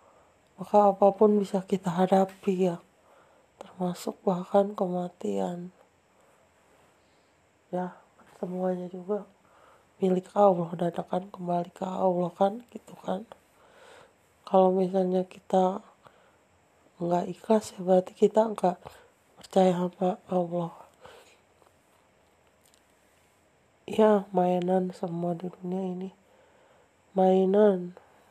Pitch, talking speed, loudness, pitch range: 185 Hz, 85 wpm, -27 LUFS, 180-200 Hz